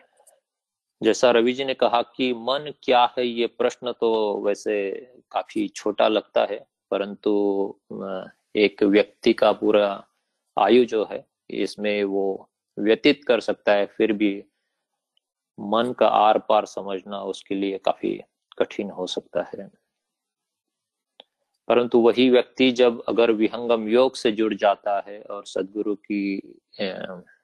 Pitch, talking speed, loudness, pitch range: 110 Hz, 125 wpm, -22 LUFS, 100-120 Hz